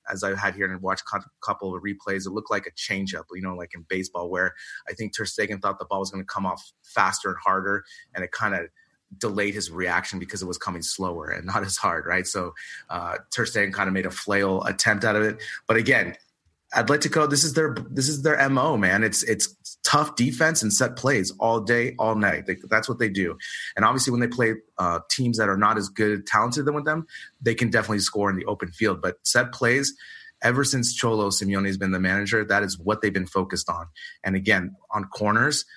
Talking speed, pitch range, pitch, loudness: 240 wpm, 95-130 Hz, 110 Hz, -24 LUFS